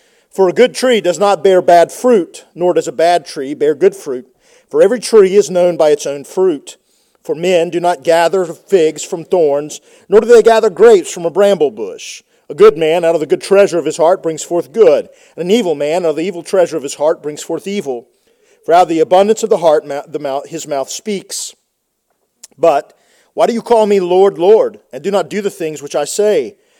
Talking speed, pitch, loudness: 230 wpm, 195 Hz, -12 LUFS